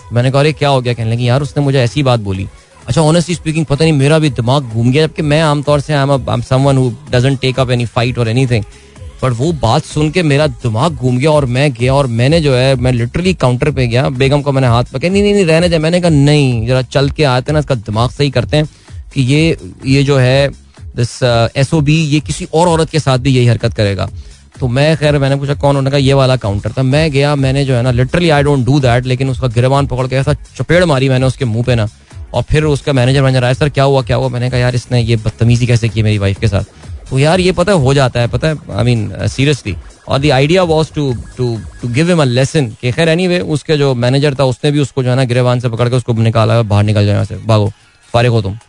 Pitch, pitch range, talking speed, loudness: 130 Hz, 120-150 Hz, 255 wpm, -12 LUFS